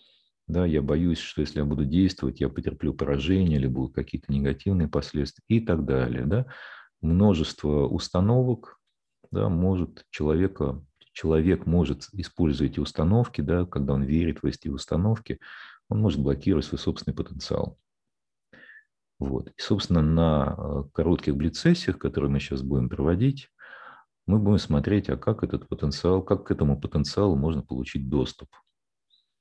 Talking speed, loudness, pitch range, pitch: 140 wpm, -26 LUFS, 70-95 Hz, 80 Hz